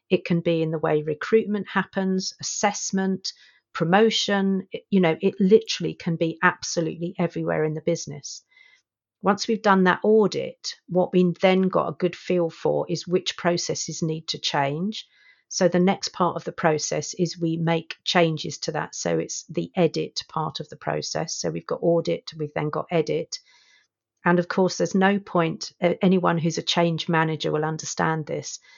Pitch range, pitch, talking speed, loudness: 165-195 Hz, 175 Hz, 175 wpm, -24 LUFS